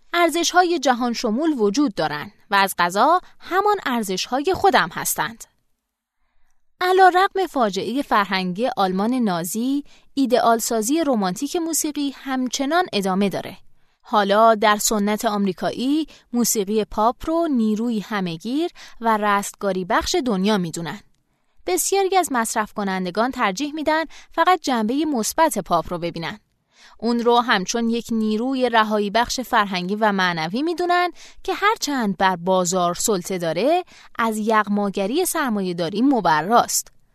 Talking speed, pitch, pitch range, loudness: 125 wpm, 230 Hz, 205-310 Hz, -20 LUFS